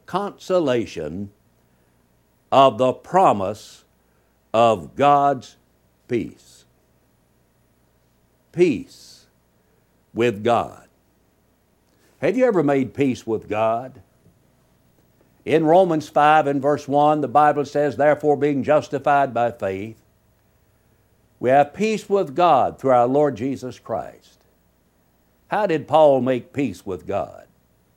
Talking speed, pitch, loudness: 105 wpm, 120 Hz, -20 LUFS